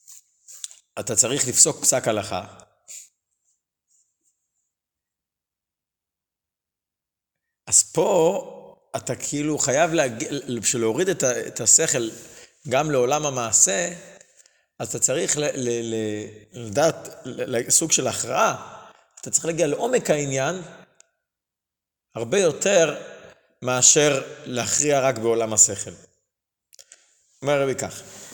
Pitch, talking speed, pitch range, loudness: 120 Hz, 85 wpm, 110-140 Hz, -20 LUFS